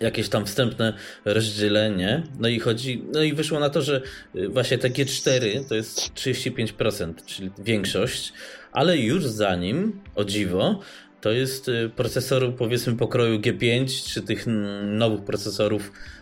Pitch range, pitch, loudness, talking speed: 105-130 Hz, 115 Hz, -24 LUFS, 135 wpm